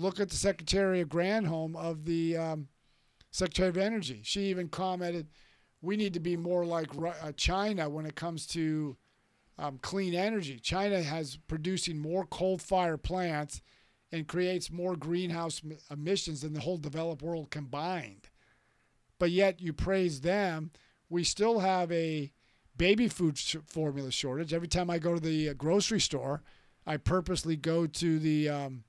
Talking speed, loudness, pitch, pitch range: 160 wpm, -32 LUFS, 165 Hz, 155-185 Hz